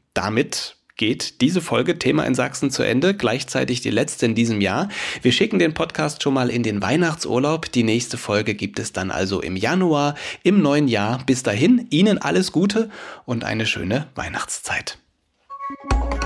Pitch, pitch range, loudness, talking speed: 125 Hz, 110-170 Hz, -20 LUFS, 165 wpm